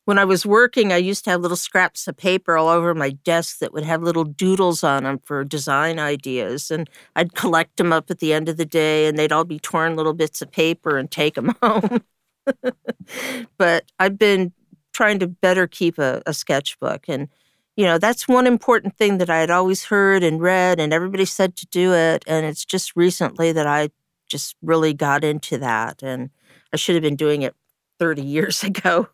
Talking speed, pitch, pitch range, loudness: 210 wpm, 170 Hz, 155-190 Hz, -19 LUFS